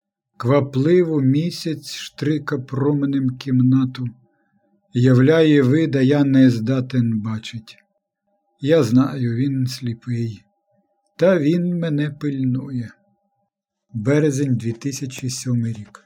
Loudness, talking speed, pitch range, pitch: -19 LUFS, 80 wpm, 125-160 Hz, 140 Hz